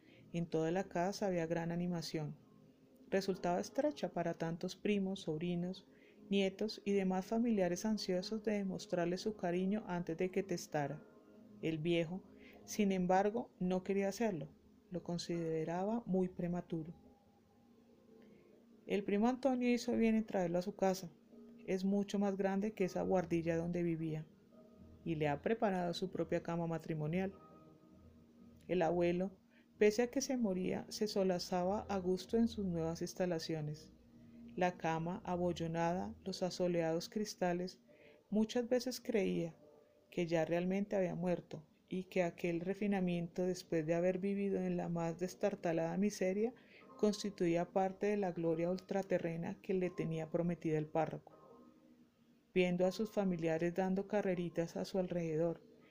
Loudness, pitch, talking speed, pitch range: -38 LUFS, 185 Hz, 135 wpm, 170-205 Hz